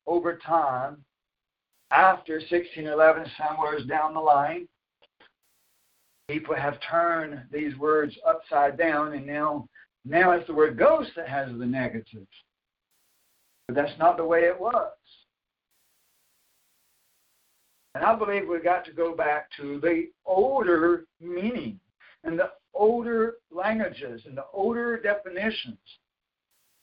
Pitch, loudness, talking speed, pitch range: 165 Hz, -25 LUFS, 120 wpm, 150-190 Hz